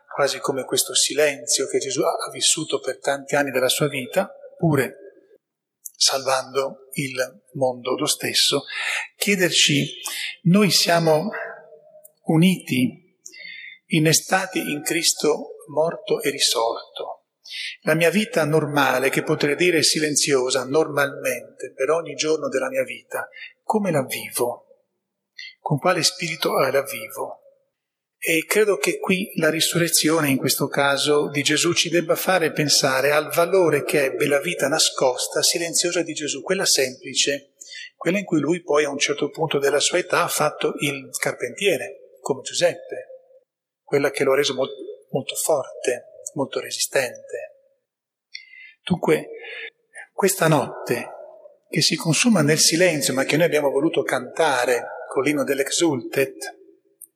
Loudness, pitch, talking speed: -21 LUFS, 170 Hz, 130 wpm